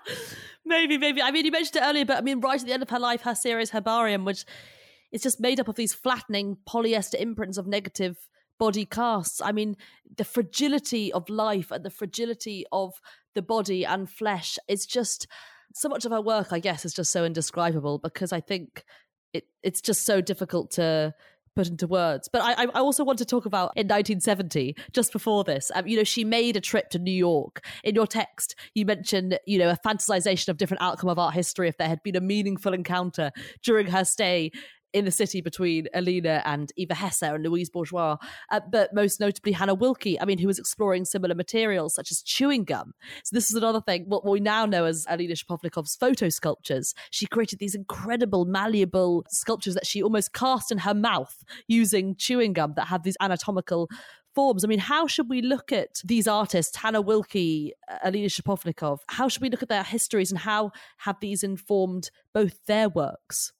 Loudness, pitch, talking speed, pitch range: -26 LUFS, 200 Hz, 200 wpm, 180-225 Hz